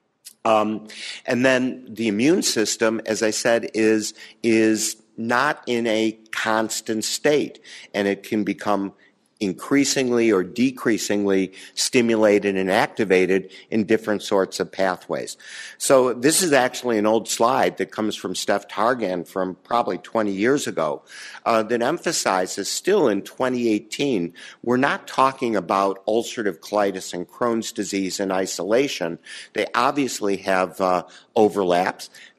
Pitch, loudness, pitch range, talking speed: 110 Hz, -22 LUFS, 100-115 Hz, 130 wpm